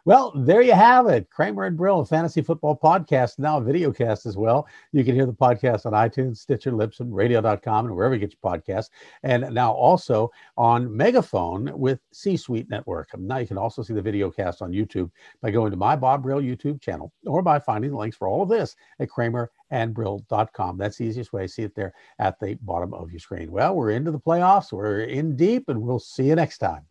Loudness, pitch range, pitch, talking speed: -22 LUFS, 105-140 Hz, 120 Hz, 225 wpm